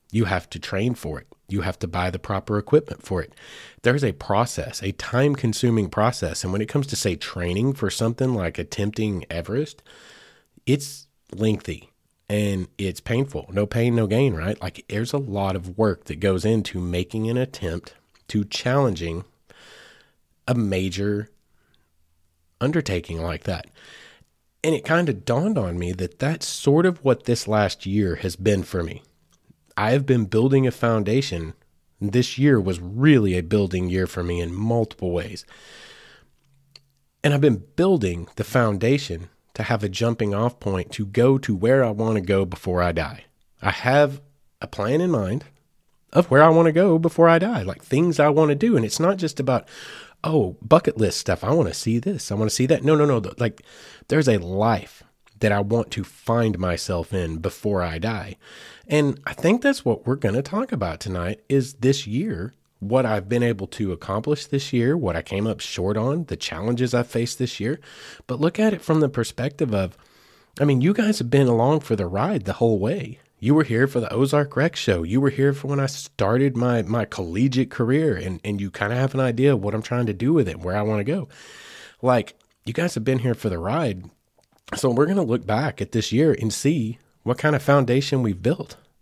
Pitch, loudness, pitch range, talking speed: 115 Hz, -22 LUFS, 95-135 Hz, 200 wpm